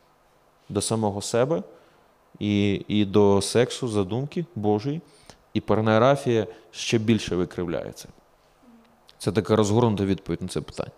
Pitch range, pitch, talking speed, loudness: 100-120 Hz, 110 Hz, 115 wpm, -24 LUFS